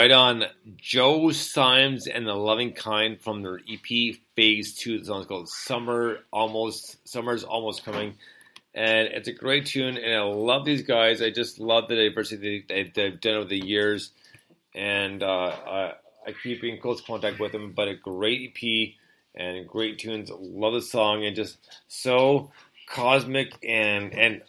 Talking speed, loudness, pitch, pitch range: 160 wpm, -25 LUFS, 110 Hz, 105-120 Hz